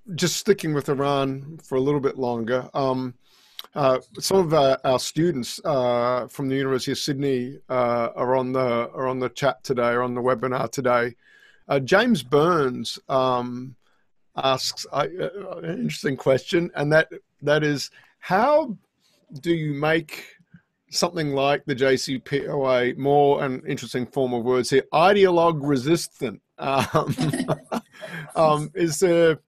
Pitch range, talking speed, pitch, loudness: 130-155 Hz, 145 wpm, 135 Hz, -23 LUFS